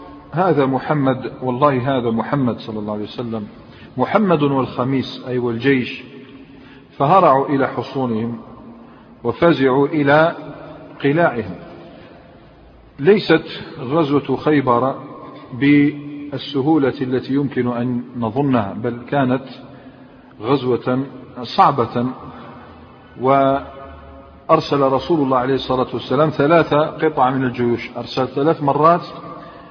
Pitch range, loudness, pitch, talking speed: 125-145 Hz, -18 LUFS, 135 Hz, 90 wpm